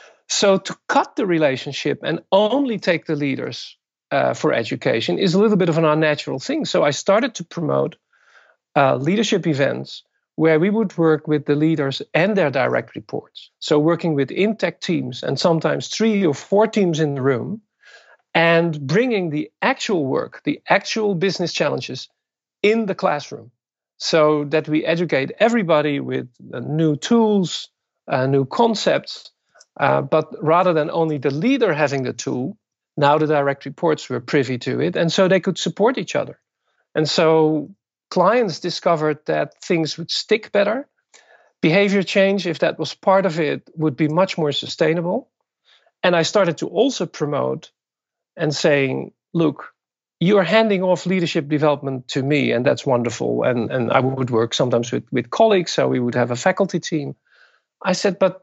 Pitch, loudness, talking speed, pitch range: 165 Hz, -19 LUFS, 170 wpm, 145-195 Hz